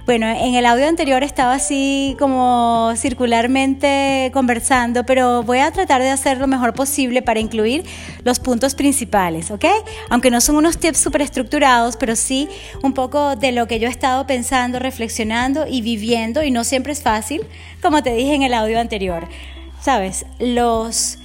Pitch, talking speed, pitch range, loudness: 255 Hz, 165 wpm, 235-275 Hz, -17 LUFS